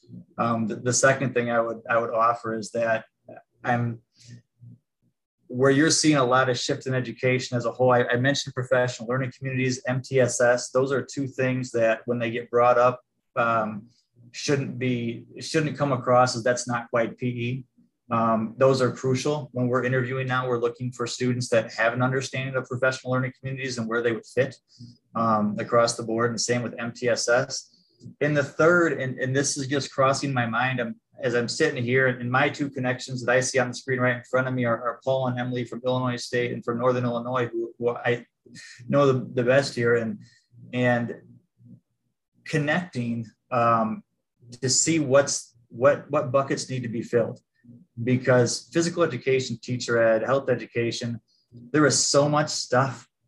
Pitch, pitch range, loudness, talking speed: 125 Hz, 120-130 Hz, -24 LUFS, 185 wpm